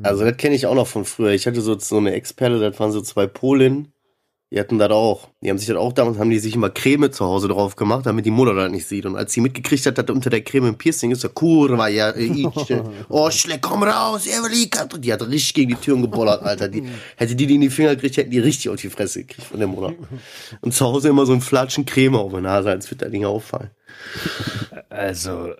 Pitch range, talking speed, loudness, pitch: 105-135 Hz, 260 wpm, -19 LUFS, 120 Hz